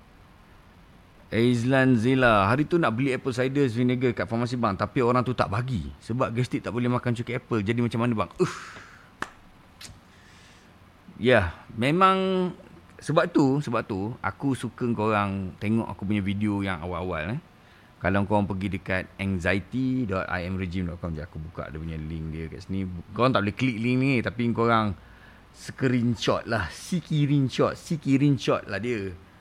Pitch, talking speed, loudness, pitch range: 115 Hz, 150 wpm, -26 LUFS, 95-125 Hz